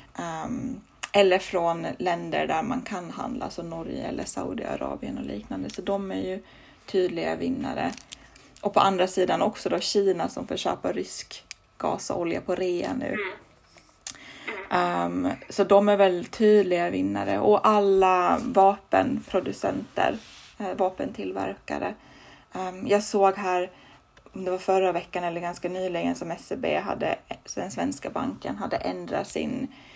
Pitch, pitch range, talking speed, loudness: 185 Hz, 175-200 Hz, 135 wpm, -26 LUFS